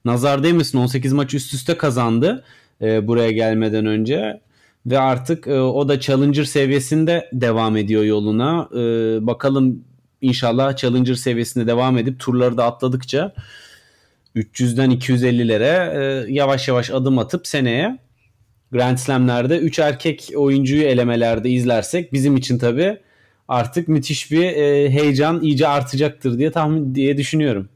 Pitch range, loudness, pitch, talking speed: 120-145 Hz, -18 LUFS, 130 Hz, 130 wpm